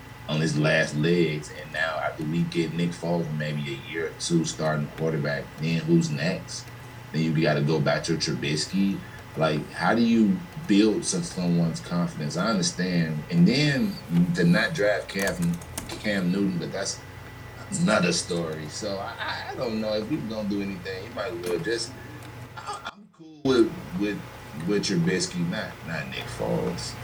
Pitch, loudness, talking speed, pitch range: 100 Hz, -26 LUFS, 170 wpm, 85-120 Hz